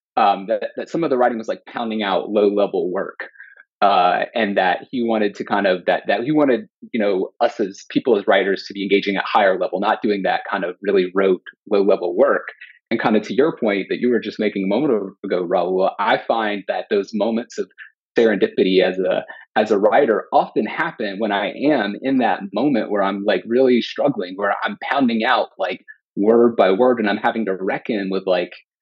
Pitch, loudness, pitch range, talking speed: 105 Hz, -19 LUFS, 95-120 Hz, 215 wpm